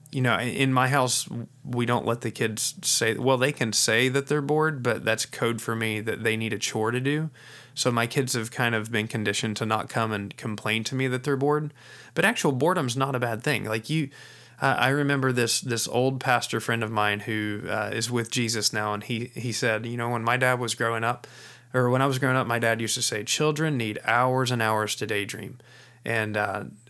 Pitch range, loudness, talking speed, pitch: 110-130 Hz, -25 LUFS, 235 wpm, 120 Hz